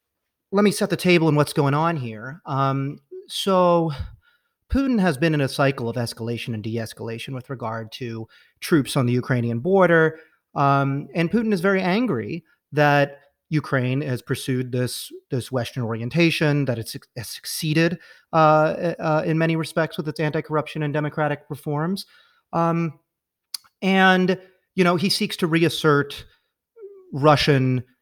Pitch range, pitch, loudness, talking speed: 135-175 Hz, 155 Hz, -22 LUFS, 145 wpm